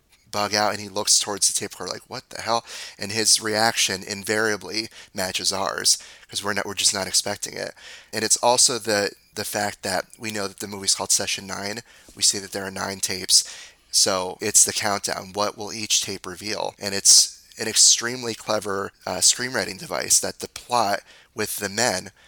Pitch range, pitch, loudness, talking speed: 95-110 Hz, 105 Hz, -21 LUFS, 195 wpm